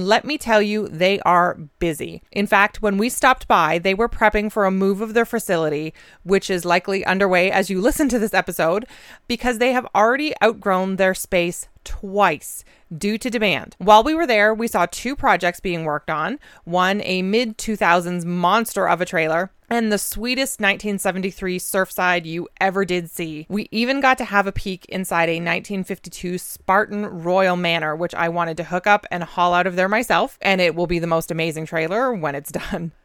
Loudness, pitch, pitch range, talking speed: -20 LUFS, 190 Hz, 175-215 Hz, 195 wpm